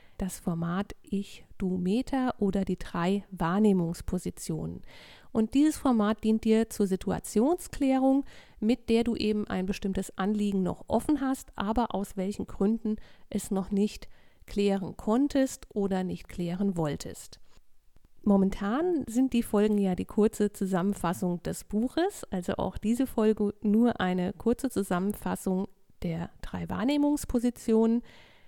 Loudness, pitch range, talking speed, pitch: -29 LUFS, 190-235 Hz, 125 wpm, 210 Hz